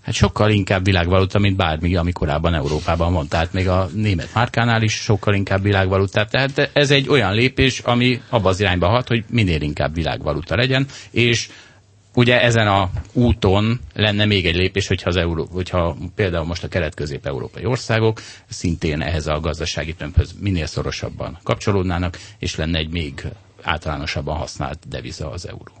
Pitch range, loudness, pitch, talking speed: 85-110 Hz, -19 LUFS, 95 Hz, 160 wpm